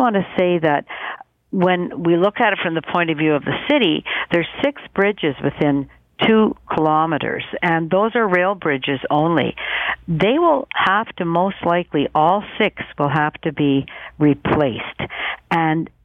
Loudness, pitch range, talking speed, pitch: -18 LUFS, 150-200 Hz, 165 wpm, 170 Hz